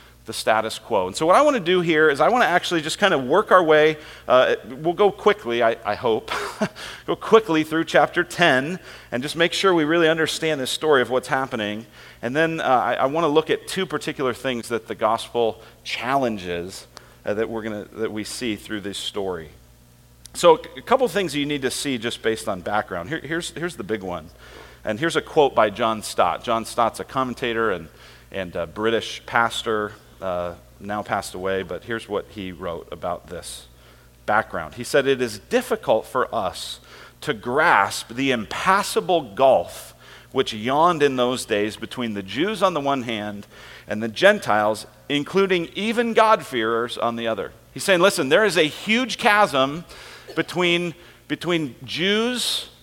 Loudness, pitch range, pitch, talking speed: -21 LUFS, 110-165 Hz, 125 Hz, 185 wpm